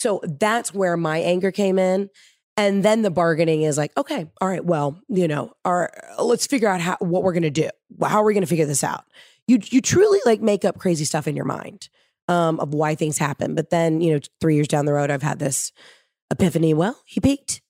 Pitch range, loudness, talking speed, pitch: 155-200 Hz, -21 LUFS, 225 wpm, 175 Hz